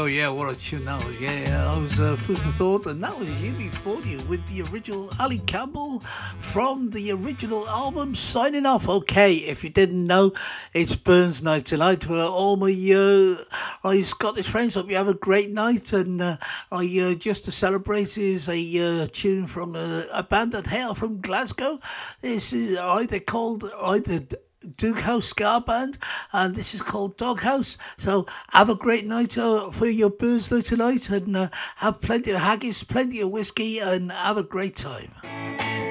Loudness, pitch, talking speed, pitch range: -22 LUFS, 195 Hz, 185 wpm, 180-220 Hz